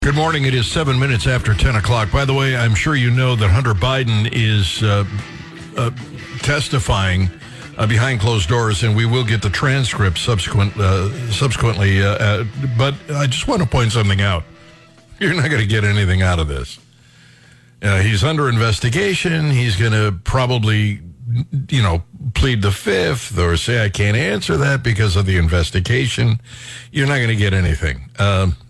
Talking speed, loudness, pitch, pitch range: 180 wpm, -17 LUFS, 115 Hz, 100-130 Hz